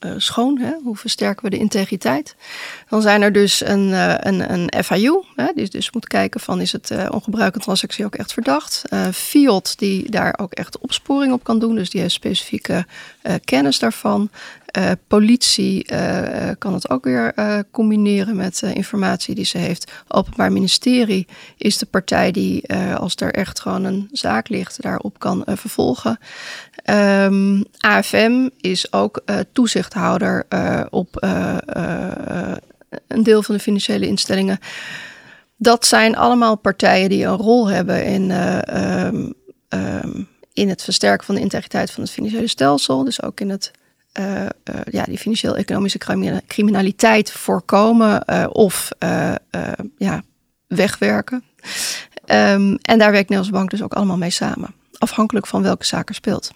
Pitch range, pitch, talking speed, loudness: 195-225 Hz, 205 Hz, 160 wpm, -18 LUFS